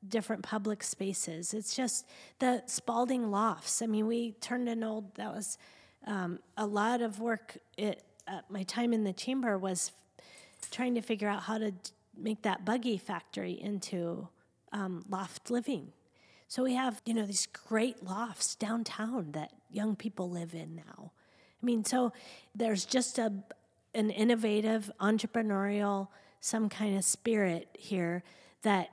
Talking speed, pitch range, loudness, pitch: 155 wpm, 195-235 Hz, -34 LUFS, 215 Hz